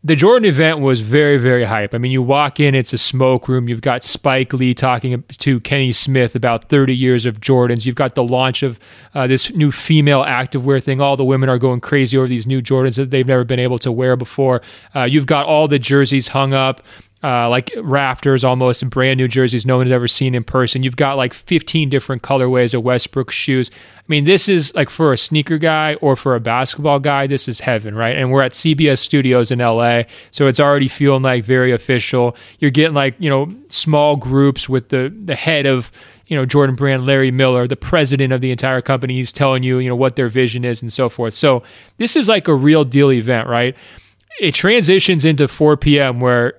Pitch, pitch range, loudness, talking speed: 130 Hz, 125-145 Hz, -14 LUFS, 225 wpm